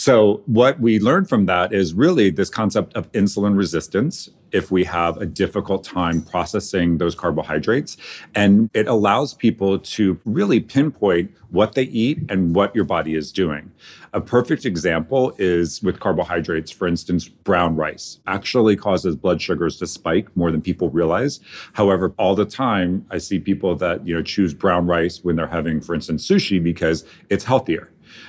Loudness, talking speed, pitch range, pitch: -19 LUFS, 170 wpm, 85-105 Hz, 95 Hz